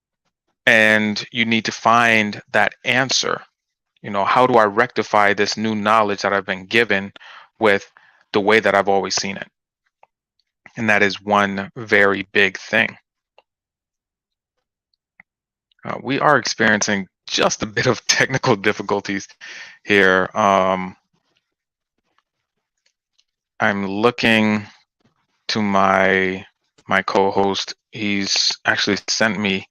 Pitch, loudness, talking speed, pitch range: 100 Hz, -17 LUFS, 115 wpm, 95-110 Hz